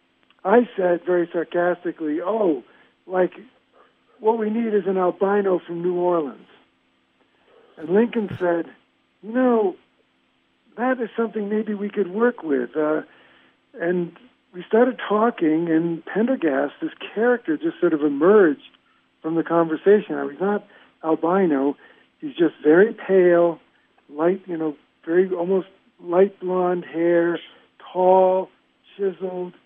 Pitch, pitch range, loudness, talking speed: 185 Hz, 170-215 Hz, -21 LUFS, 120 wpm